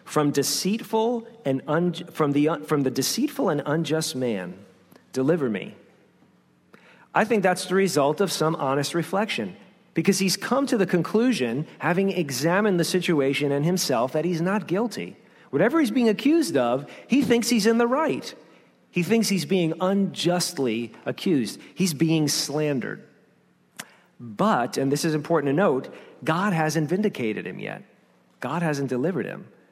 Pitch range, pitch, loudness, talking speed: 145-200 Hz, 170 Hz, -24 LUFS, 150 wpm